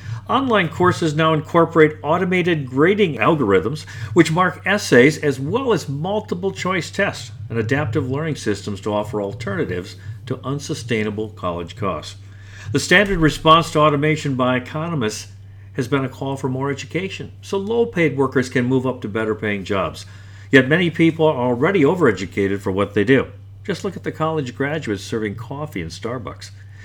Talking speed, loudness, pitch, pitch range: 160 wpm, -19 LUFS, 135 Hz, 105-160 Hz